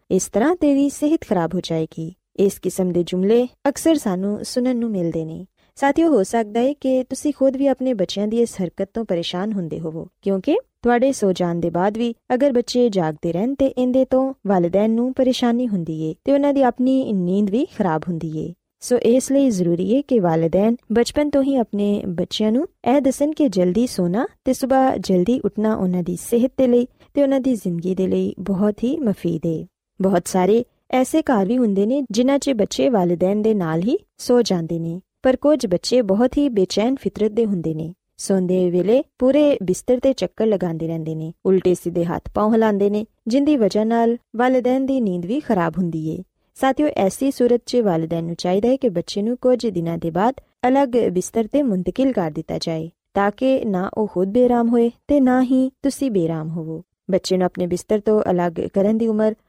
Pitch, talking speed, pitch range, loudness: 215 Hz, 135 wpm, 180-255 Hz, -19 LUFS